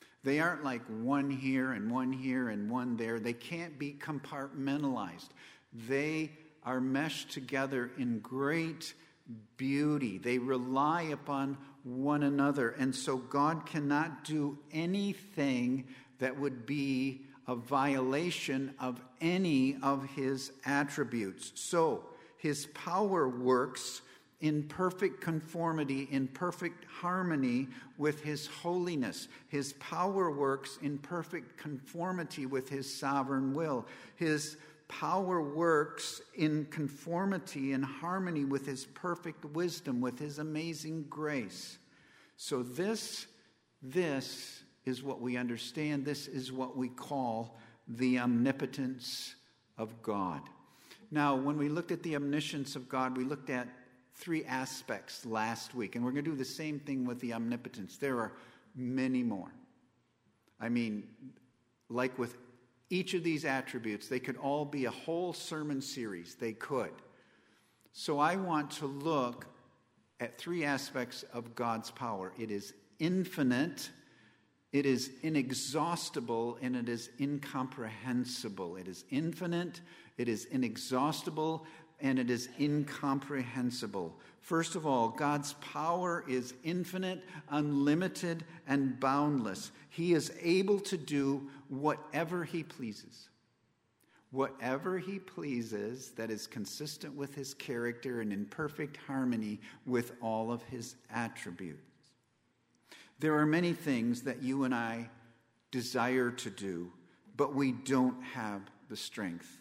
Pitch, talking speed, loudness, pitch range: 135 Hz, 125 wpm, -36 LUFS, 125-155 Hz